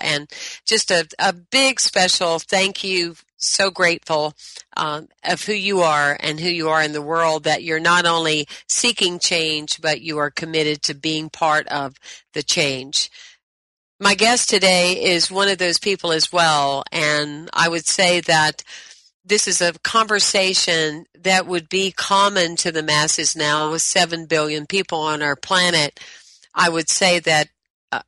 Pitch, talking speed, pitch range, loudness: 165 Hz, 160 wpm, 155-185 Hz, -18 LUFS